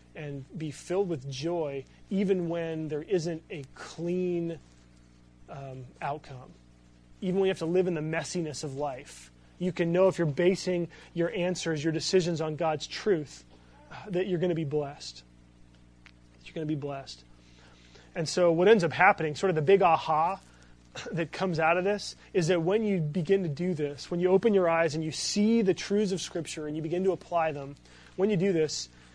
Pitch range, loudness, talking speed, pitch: 135-180 Hz, -28 LUFS, 195 wpm, 160 Hz